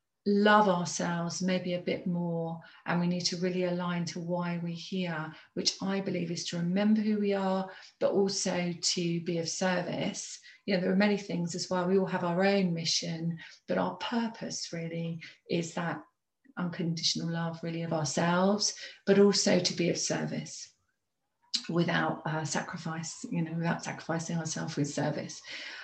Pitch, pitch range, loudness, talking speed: 175 Hz, 165-190 Hz, -31 LUFS, 165 wpm